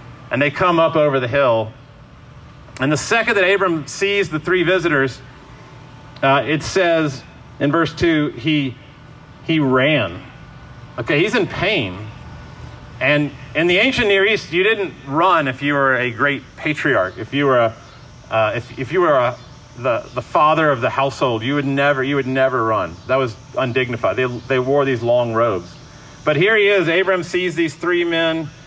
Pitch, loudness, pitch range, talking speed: 145 Hz, -17 LUFS, 130-160 Hz, 180 wpm